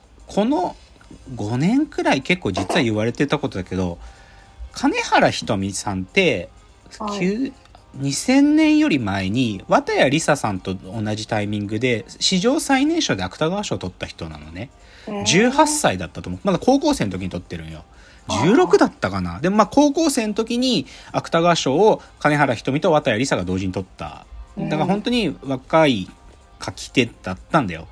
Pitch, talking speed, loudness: 130 Hz, 300 characters per minute, -20 LUFS